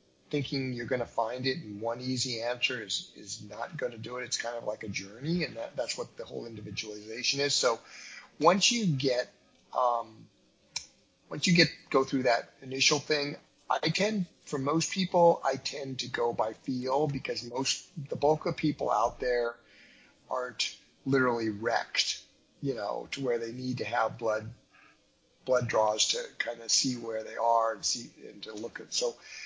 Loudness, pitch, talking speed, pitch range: -30 LUFS, 130 Hz, 185 wpm, 115-150 Hz